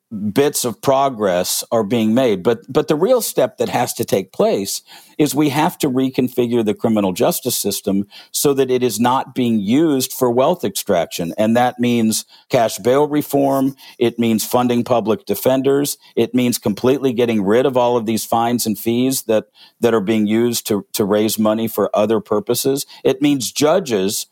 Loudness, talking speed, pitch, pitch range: -17 LUFS, 180 wpm, 120 Hz, 110-135 Hz